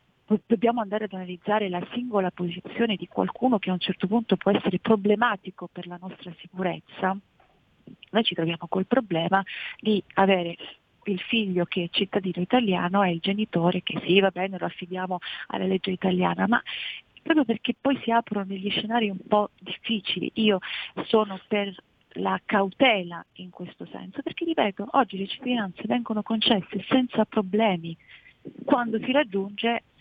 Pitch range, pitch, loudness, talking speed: 185-225 Hz, 200 Hz, -26 LUFS, 155 wpm